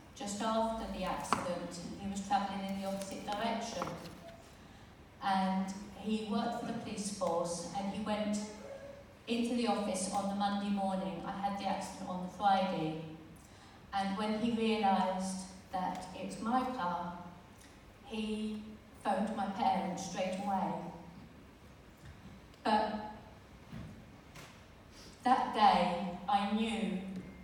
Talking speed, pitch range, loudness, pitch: 120 wpm, 190-215 Hz, -36 LUFS, 200 Hz